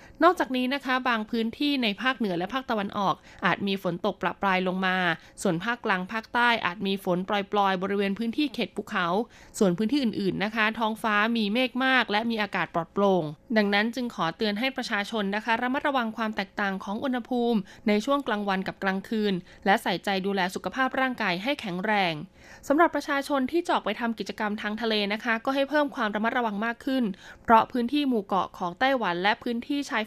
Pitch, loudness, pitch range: 215 Hz, -26 LUFS, 195-245 Hz